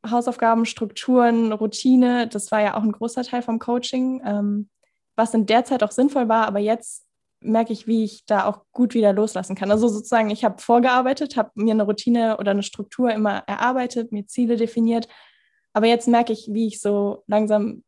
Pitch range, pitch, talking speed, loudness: 210-240 Hz, 225 Hz, 190 wpm, -21 LUFS